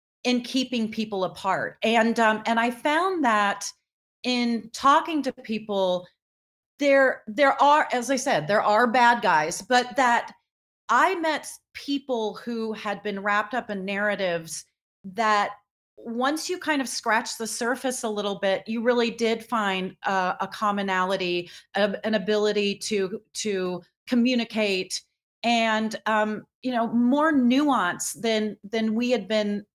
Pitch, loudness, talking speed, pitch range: 220 Hz, -24 LUFS, 145 wpm, 205-245 Hz